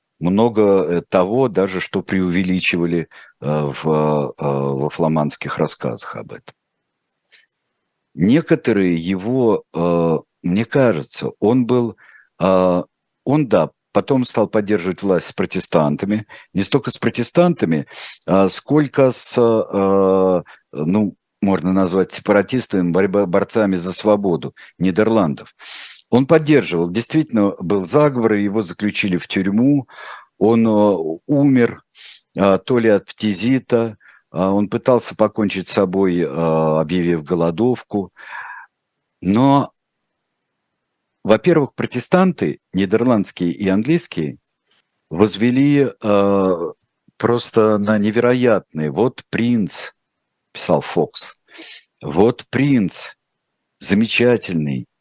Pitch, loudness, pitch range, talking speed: 100 Hz, -17 LUFS, 90-120 Hz, 85 wpm